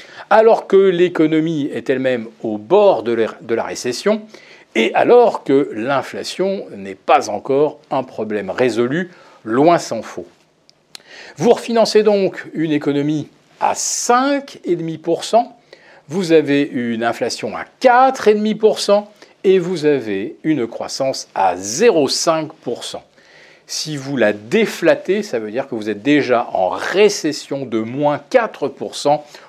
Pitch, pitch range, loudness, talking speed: 155 Hz, 130-205 Hz, -17 LUFS, 120 wpm